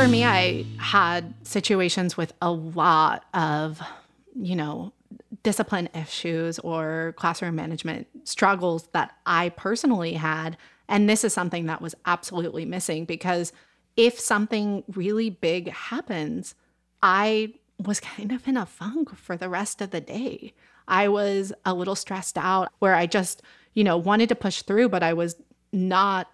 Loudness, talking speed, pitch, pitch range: -25 LUFS, 155 wpm, 185 Hz, 165-210 Hz